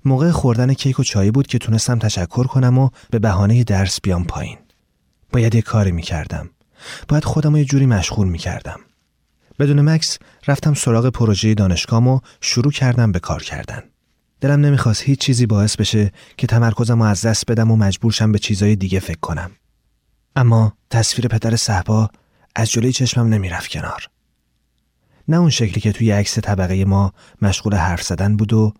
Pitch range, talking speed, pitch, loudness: 100-125 Hz, 170 wpm, 110 Hz, -17 LUFS